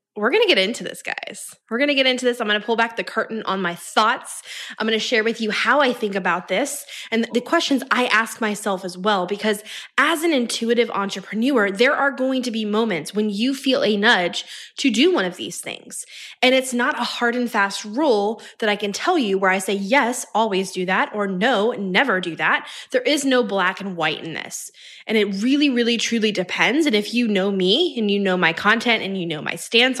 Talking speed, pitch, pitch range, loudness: 235 wpm, 225 Hz, 200-255 Hz, -20 LUFS